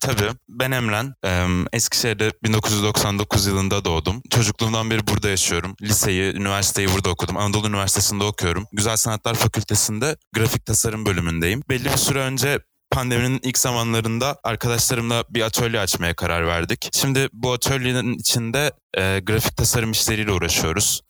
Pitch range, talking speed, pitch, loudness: 100-120 Hz, 135 wpm, 110 Hz, -20 LUFS